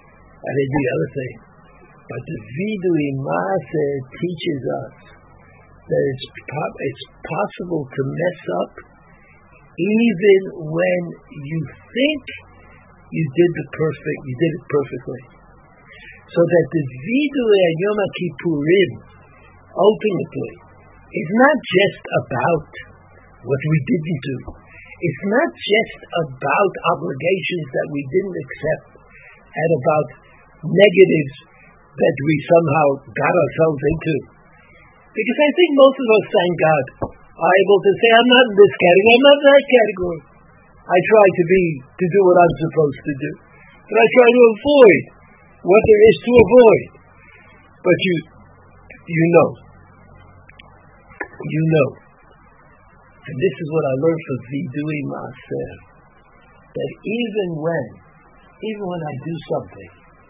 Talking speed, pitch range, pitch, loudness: 130 wpm, 145-200 Hz, 170 Hz, -17 LUFS